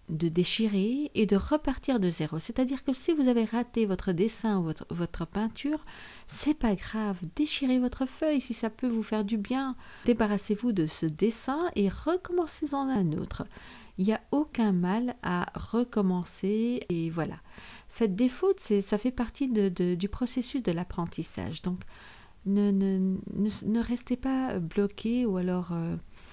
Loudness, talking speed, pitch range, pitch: -29 LUFS, 165 wpm, 185-255 Hz, 220 Hz